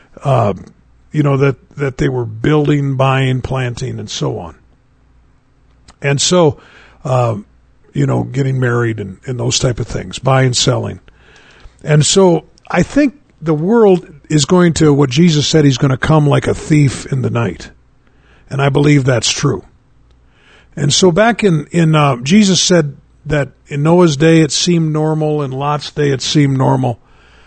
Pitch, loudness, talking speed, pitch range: 140 Hz, -13 LUFS, 165 wpm, 125-160 Hz